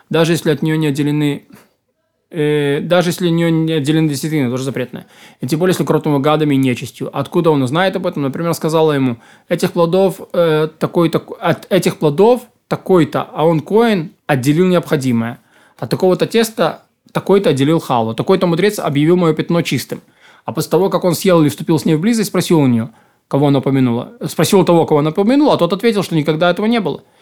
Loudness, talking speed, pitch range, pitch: -15 LUFS, 195 wpm, 150-180 Hz, 160 Hz